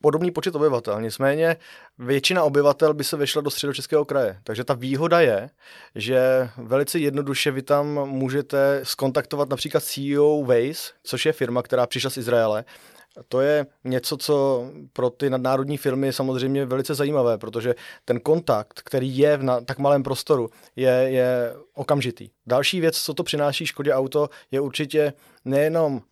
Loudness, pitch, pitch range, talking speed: -22 LUFS, 140 Hz, 130-150 Hz, 155 wpm